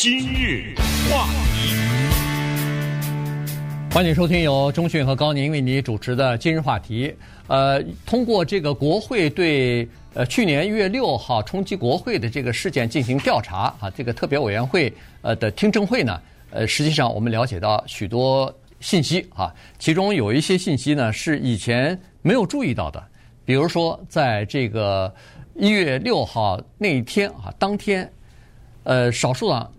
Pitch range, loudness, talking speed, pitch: 120-160 Hz, -21 LUFS, 235 characters per minute, 140 Hz